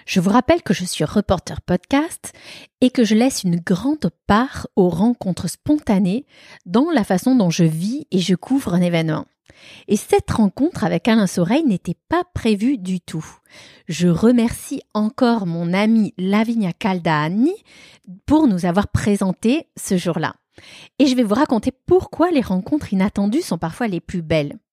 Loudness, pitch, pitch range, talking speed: -19 LUFS, 205 Hz, 180-250 Hz, 165 wpm